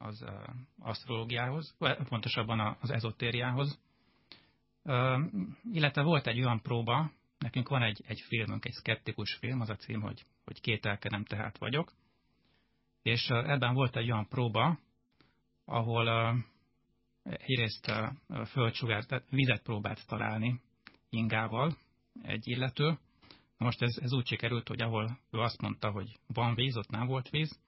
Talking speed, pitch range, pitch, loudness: 130 wpm, 110-130 Hz, 120 Hz, -34 LUFS